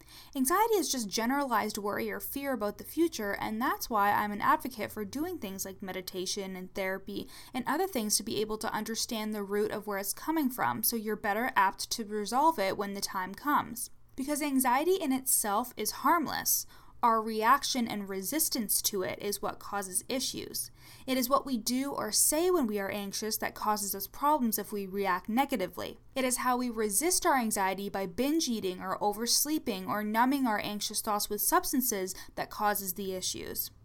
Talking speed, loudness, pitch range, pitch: 190 wpm, -31 LUFS, 200-265 Hz, 215 Hz